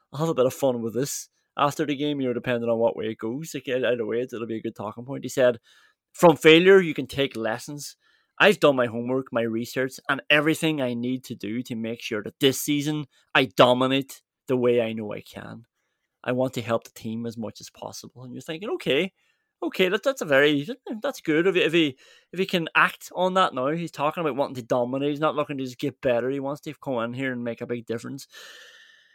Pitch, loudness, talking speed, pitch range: 135 Hz, -24 LUFS, 240 wpm, 120-155 Hz